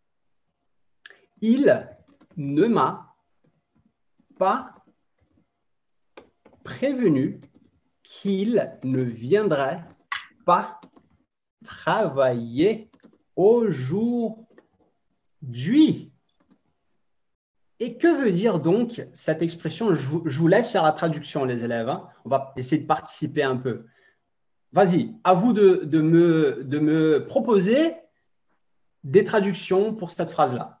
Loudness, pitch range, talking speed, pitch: -22 LUFS, 150-220 Hz, 95 wpm, 175 Hz